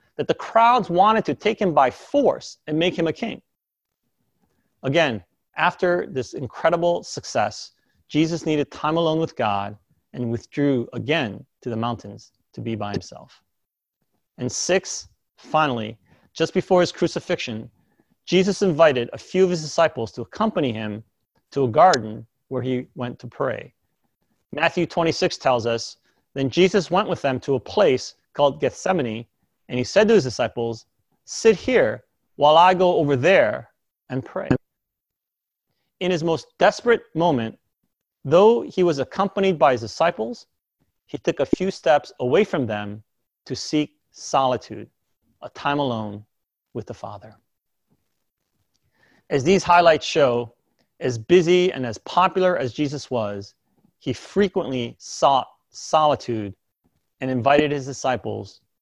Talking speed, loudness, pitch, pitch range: 140 wpm, -21 LUFS, 140 Hz, 115-175 Hz